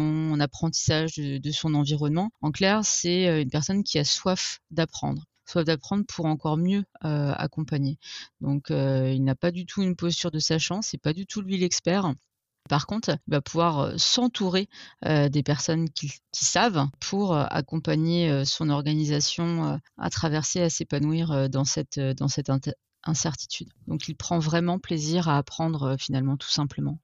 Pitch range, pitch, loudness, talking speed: 145-170 Hz, 155 Hz, -26 LUFS, 155 wpm